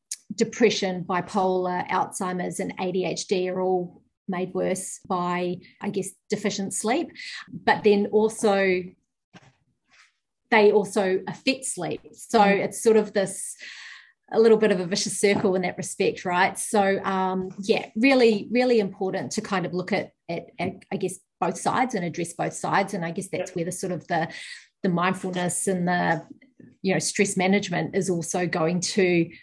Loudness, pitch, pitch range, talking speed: -24 LUFS, 195 Hz, 180-210 Hz, 160 wpm